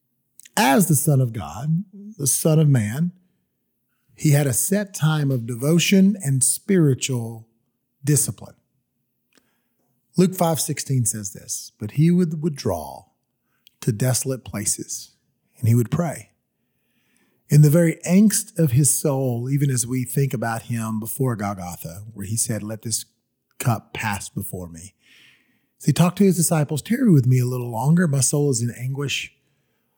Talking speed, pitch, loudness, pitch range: 150 wpm, 135 Hz, -21 LUFS, 120-160 Hz